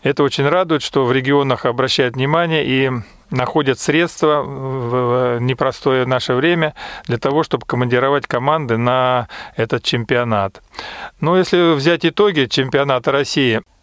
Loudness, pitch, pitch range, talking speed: -16 LUFS, 135 Hz, 125-150 Hz, 125 wpm